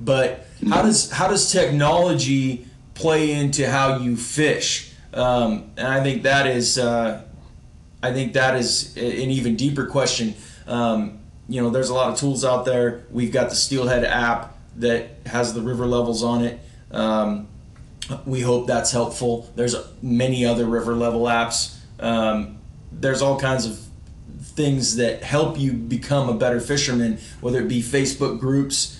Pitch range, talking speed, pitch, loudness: 115-135 Hz, 160 wpm, 125 Hz, -21 LUFS